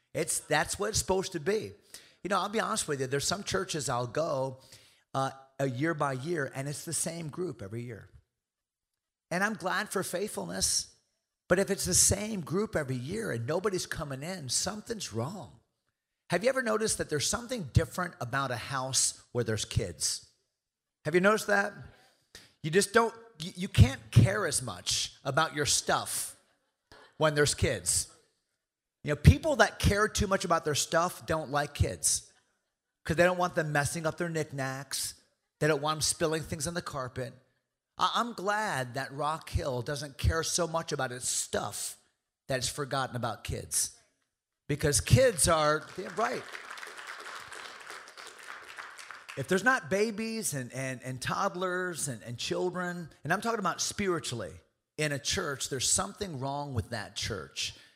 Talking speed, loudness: 165 wpm, -30 LUFS